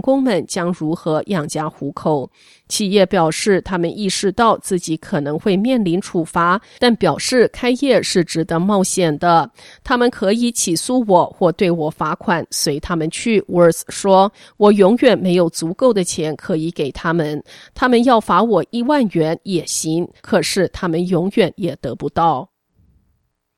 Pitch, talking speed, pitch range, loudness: 180 Hz, 240 characters per minute, 165-205 Hz, -17 LUFS